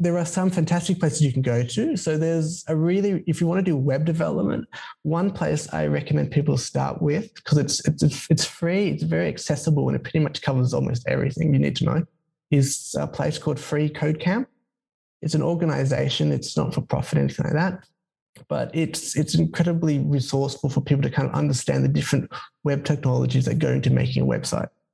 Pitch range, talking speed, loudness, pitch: 135-165 Hz, 200 wpm, -23 LUFS, 150 Hz